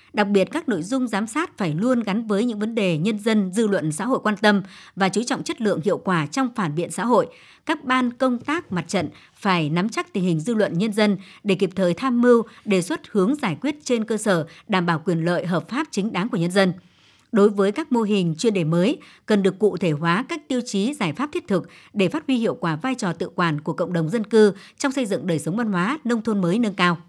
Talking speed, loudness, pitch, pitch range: 265 wpm, -22 LUFS, 205 Hz, 180-240 Hz